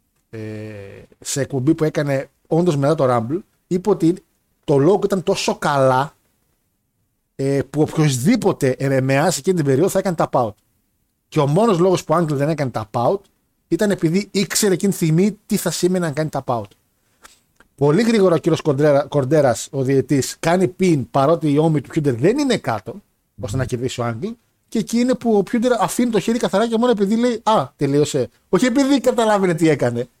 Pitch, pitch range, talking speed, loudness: 160 Hz, 135-195 Hz, 190 wpm, -18 LUFS